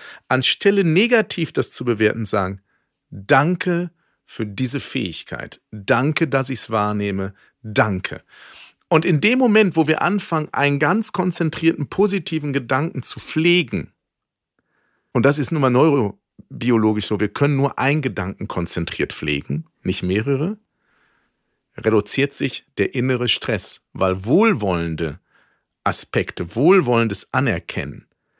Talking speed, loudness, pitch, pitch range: 120 wpm, -19 LUFS, 135 Hz, 105-160 Hz